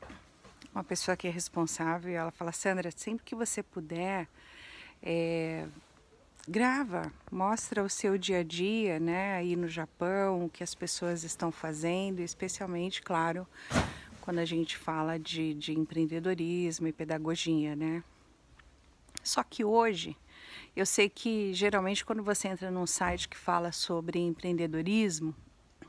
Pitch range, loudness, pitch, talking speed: 165-195 Hz, -33 LUFS, 175 Hz, 135 wpm